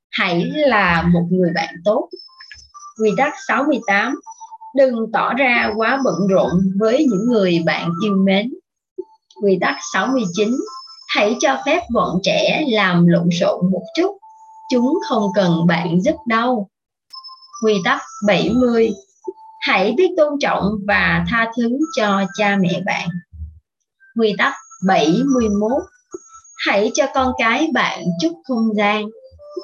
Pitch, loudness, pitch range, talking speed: 230 Hz, -17 LUFS, 195-310 Hz, 130 wpm